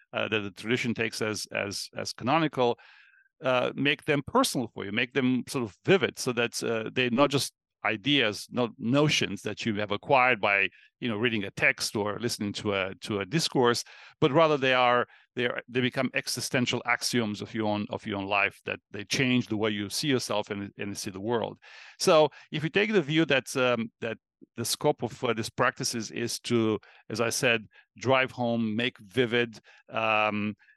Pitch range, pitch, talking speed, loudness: 105-130 Hz, 120 Hz, 200 wpm, -27 LUFS